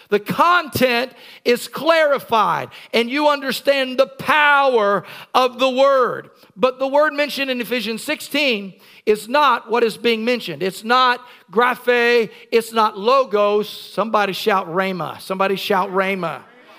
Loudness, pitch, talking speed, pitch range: -18 LUFS, 240 Hz, 130 wpm, 205-265 Hz